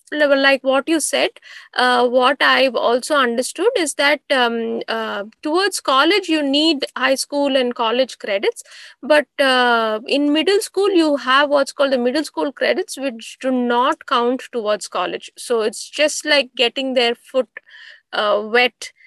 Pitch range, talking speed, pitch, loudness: 245-300 Hz, 160 wpm, 270 Hz, -17 LUFS